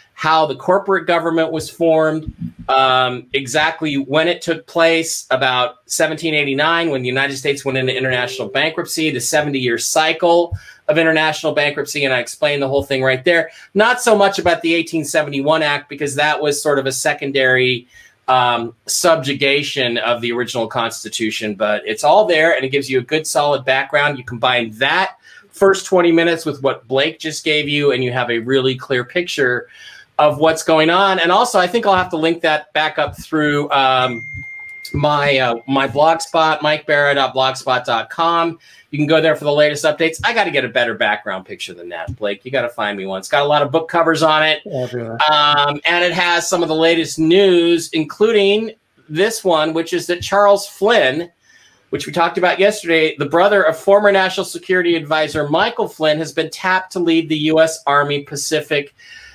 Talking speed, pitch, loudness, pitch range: 185 wpm, 155 Hz, -16 LUFS, 135-165 Hz